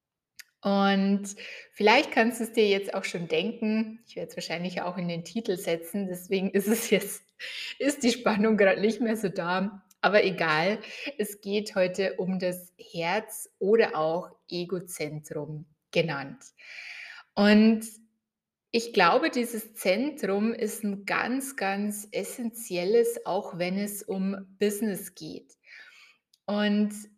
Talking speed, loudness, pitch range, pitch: 130 wpm, -27 LUFS, 185-220 Hz, 200 Hz